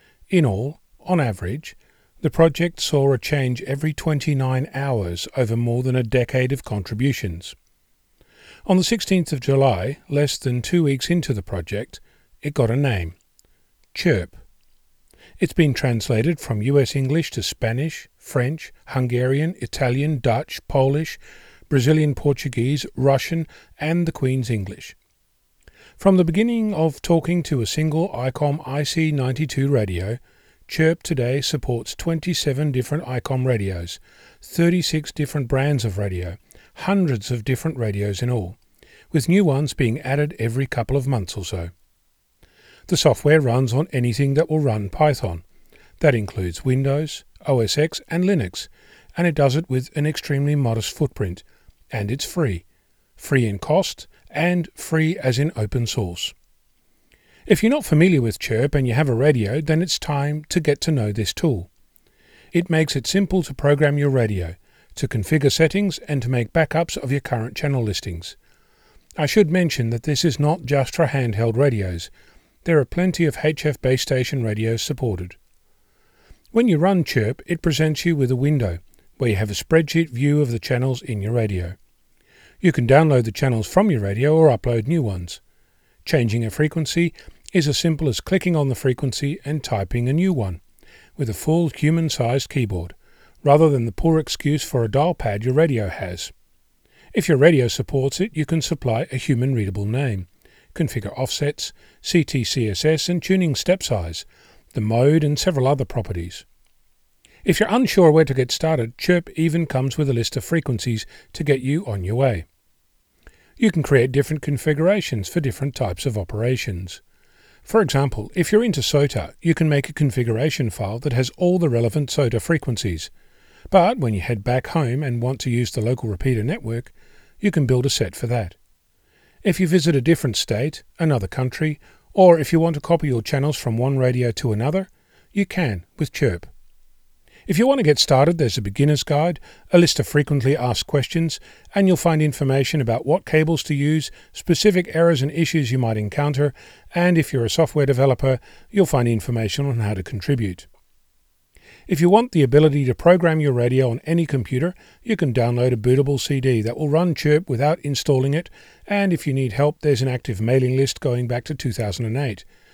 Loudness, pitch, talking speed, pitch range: -20 LUFS, 140 Hz, 170 wpm, 120-160 Hz